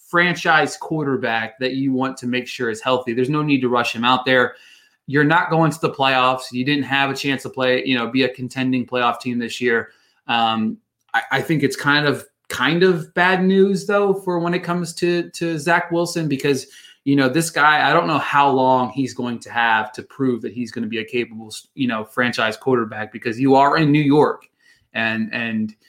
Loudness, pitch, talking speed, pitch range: -19 LUFS, 130 Hz, 220 wpm, 120-155 Hz